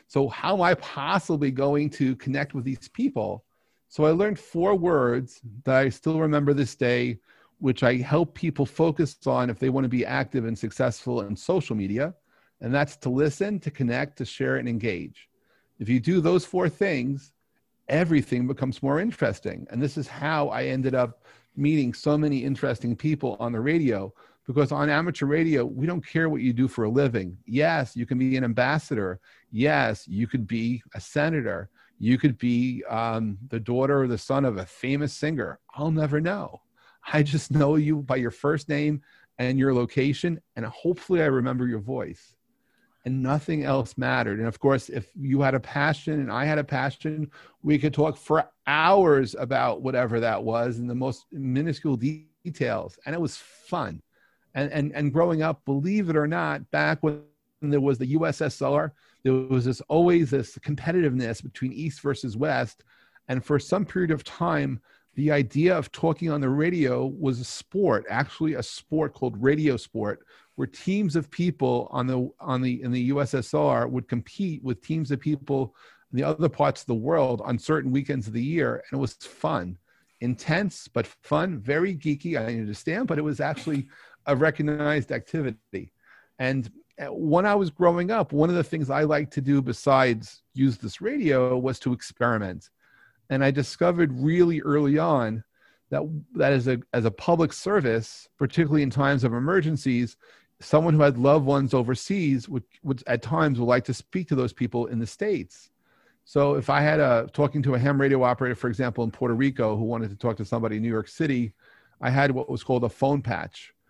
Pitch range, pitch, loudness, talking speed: 125-155 Hz, 140 Hz, -25 LUFS, 190 wpm